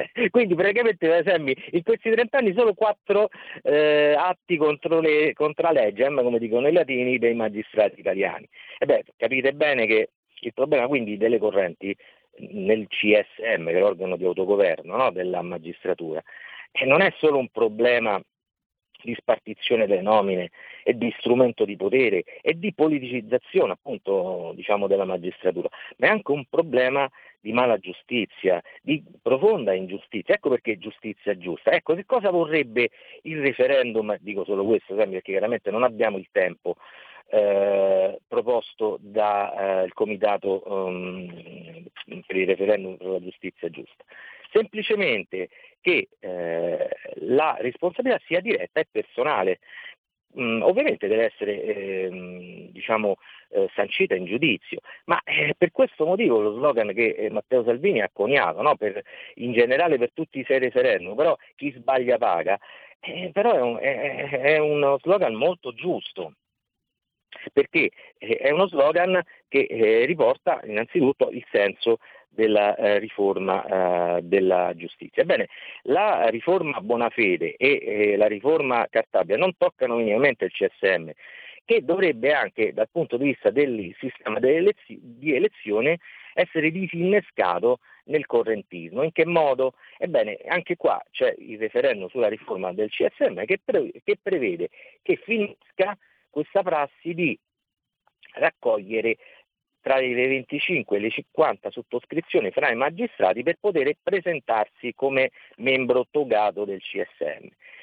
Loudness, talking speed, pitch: -23 LUFS, 140 wpm, 175 Hz